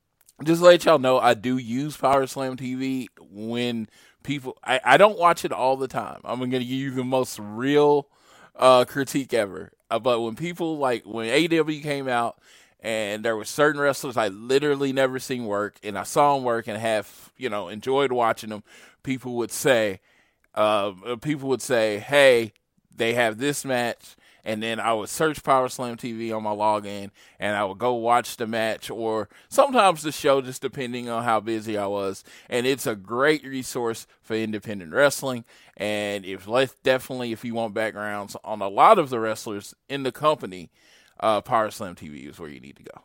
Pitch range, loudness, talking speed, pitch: 110-135 Hz, -23 LUFS, 190 wpm, 120 Hz